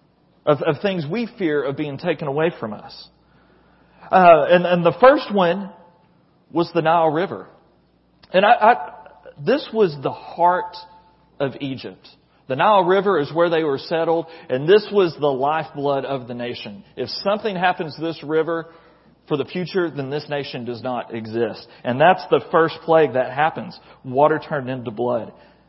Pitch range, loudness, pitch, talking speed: 140-175 Hz, -19 LUFS, 165 Hz, 170 wpm